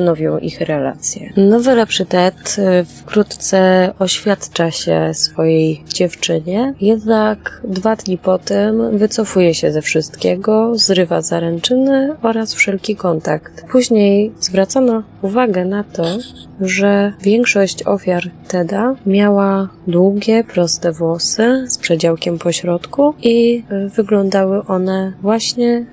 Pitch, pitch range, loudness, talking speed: 195 Hz, 175-220 Hz, -14 LUFS, 105 wpm